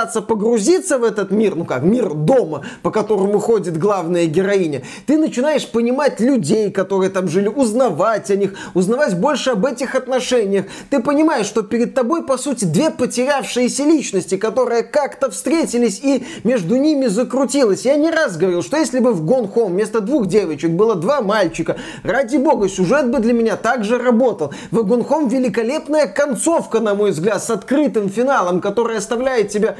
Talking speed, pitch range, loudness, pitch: 165 wpm, 205-270 Hz, -17 LUFS, 235 Hz